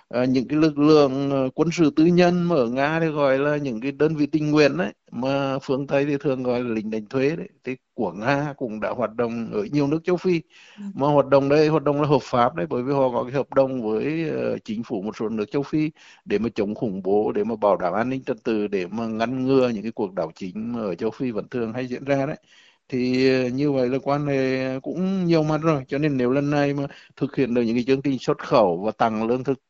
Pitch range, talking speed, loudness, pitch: 125-150 Hz, 265 wpm, -23 LUFS, 140 Hz